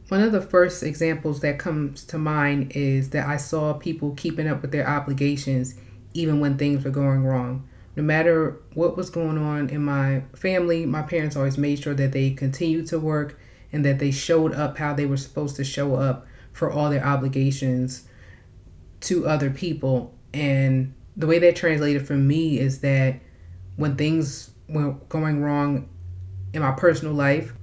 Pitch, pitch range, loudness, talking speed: 145 Hz, 135-155 Hz, -23 LUFS, 175 wpm